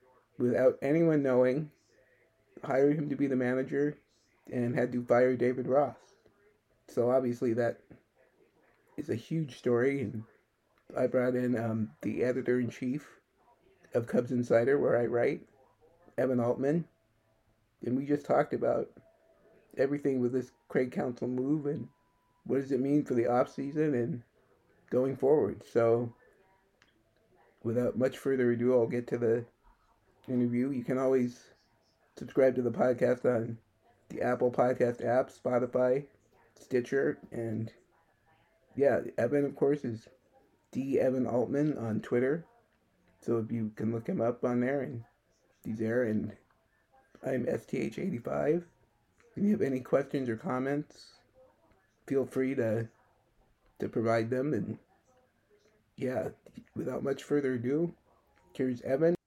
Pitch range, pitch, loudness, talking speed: 115-135 Hz, 125 Hz, -31 LUFS, 135 wpm